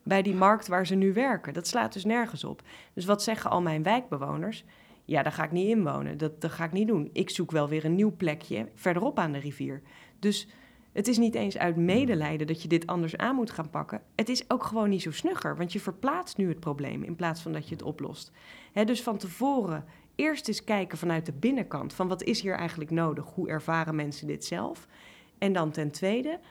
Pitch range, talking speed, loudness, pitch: 160-220 Hz, 230 wpm, -29 LUFS, 180 Hz